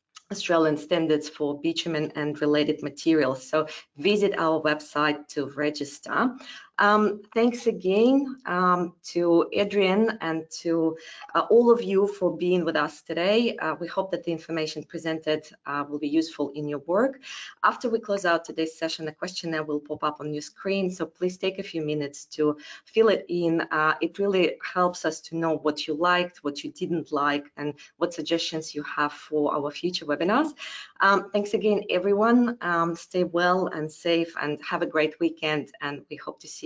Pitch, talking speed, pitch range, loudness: 165 Hz, 180 wpm, 150-190 Hz, -26 LUFS